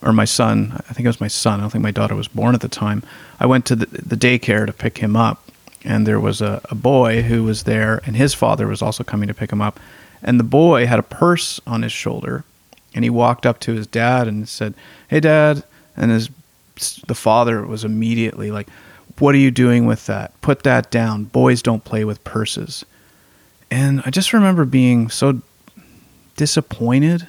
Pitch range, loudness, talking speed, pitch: 110-130 Hz, -17 LUFS, 210 wpm, 115 Hz